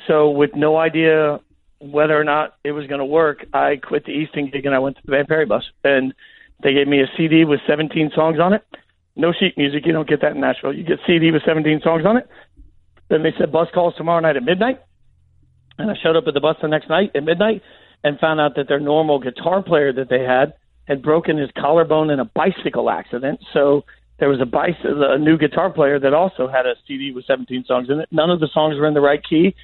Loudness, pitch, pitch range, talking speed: -18 LUFS, 150 Hz, 140-160 Hz, 245 wpm